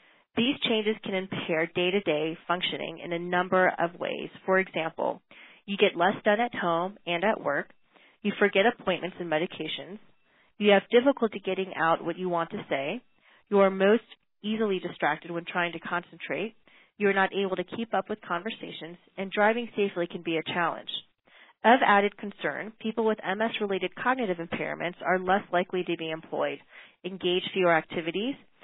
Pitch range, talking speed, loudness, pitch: 170-210 Hz, 165 wpm, -28 LUFS, 190 Hz